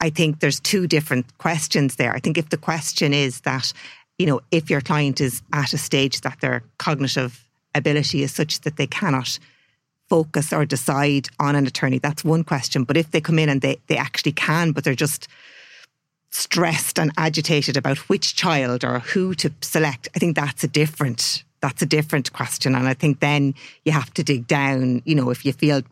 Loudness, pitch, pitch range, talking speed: -21 LUFS, 145 Hz, 135-160 Hz, 200 wpm